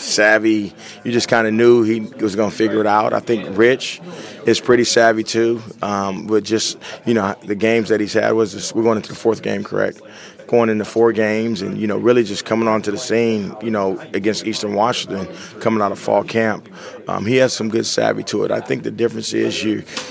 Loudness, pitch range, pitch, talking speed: -18 LUFS, 105-115 Hz, 110 Hz, 225 wpm